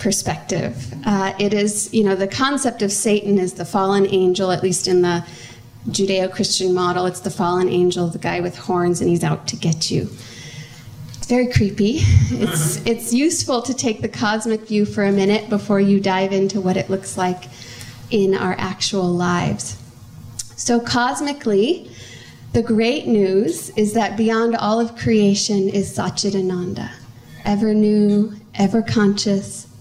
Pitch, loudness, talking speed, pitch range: 195 Hz, -19 LUFS, 155 wpm, 175-210 Hz